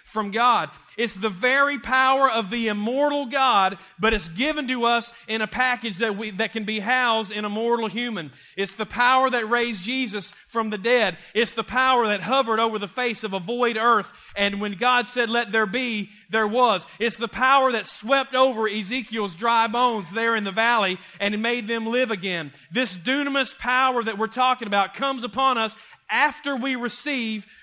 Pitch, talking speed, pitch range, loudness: 230 Hz, 195 wpm, 215-255 Hz, -22 LUFS